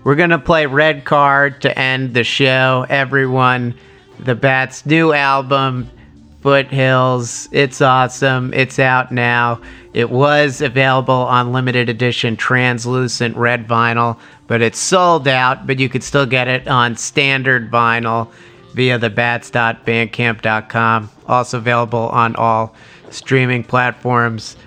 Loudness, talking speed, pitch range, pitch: -14 LUFS, 125 wpm, 120-135 Hz, 125 Hz